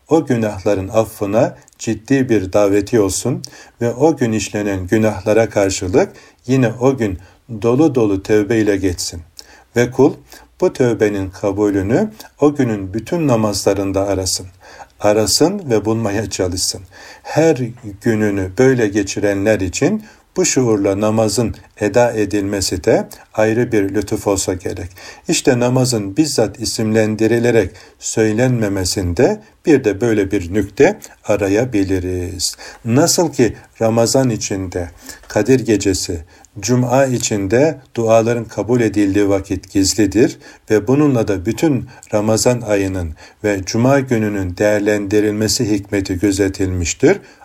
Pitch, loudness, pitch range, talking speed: 105 Hz, -16 LUFS, 100-120 Hz, 110 wpm